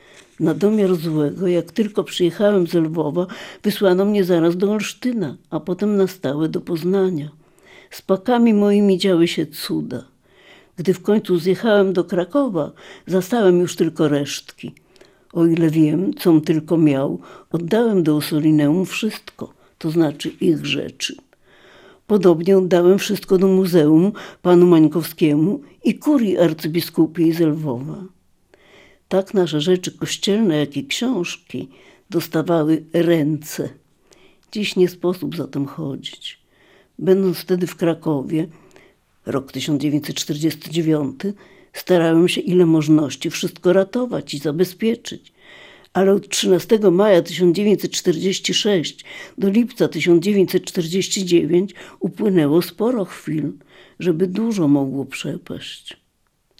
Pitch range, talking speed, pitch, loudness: 160-190 Hz, 110 wpm, 175 Hz, -18 LUFS